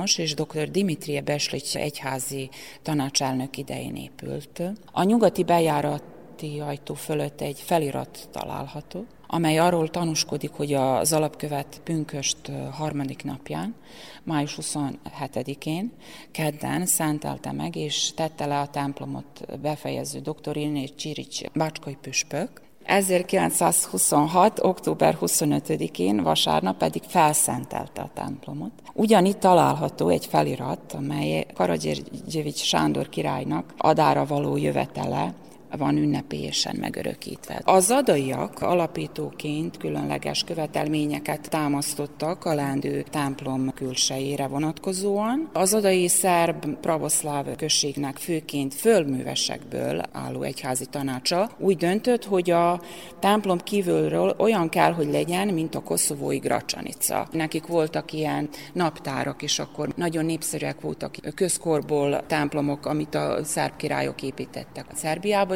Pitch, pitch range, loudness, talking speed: 150 Hz, 140-170 Hz, -25 LUFS, 105 wpm